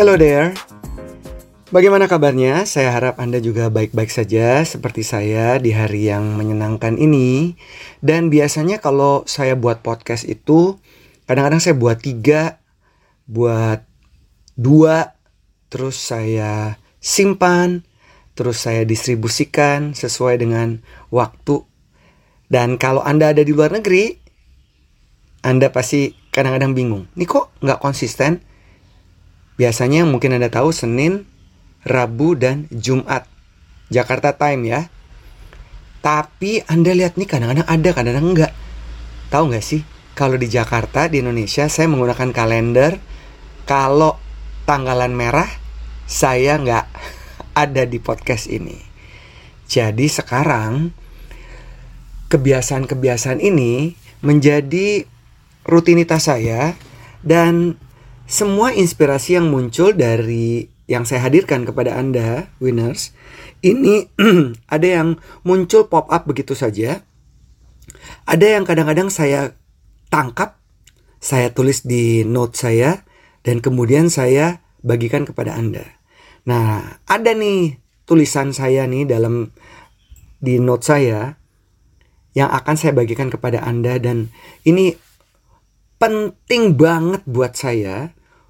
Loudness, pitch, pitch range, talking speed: -16 LUFS, 130 Hz, 115-155 Hz, 110 wpm